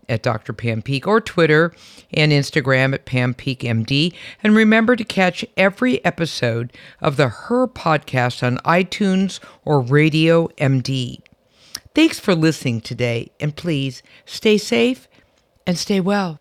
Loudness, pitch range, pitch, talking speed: -18 LUFS, 130-190 Hz, 155 Hz, 140 wpm